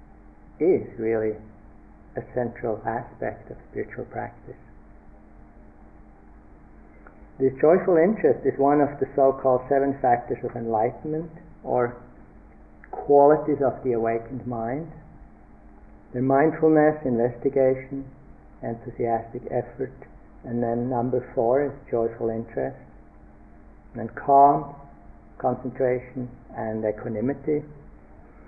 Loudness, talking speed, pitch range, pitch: -24 LUFS, 95 wpm, 105-135 Hz, 120 Hz